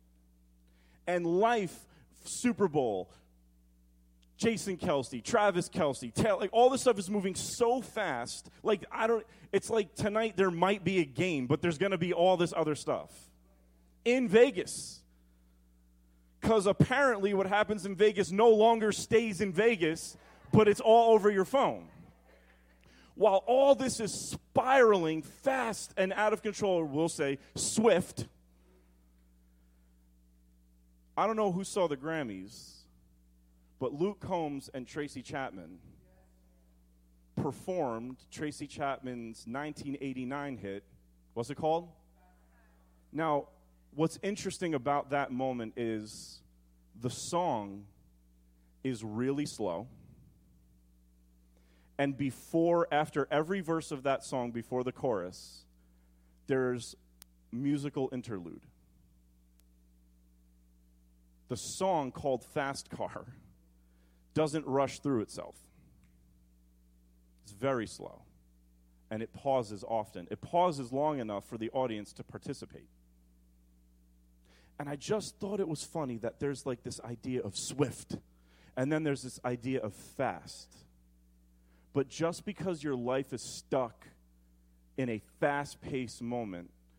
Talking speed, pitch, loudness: 120 wpm, 125 Hz, -32 LUFS